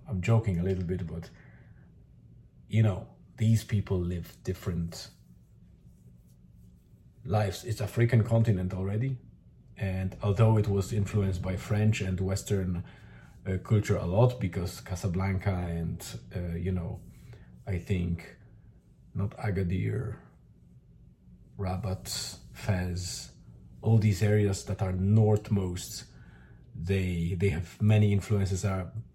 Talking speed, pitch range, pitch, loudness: 110 wpm, 90-105 Hz, 95 Hz, -30 LUFS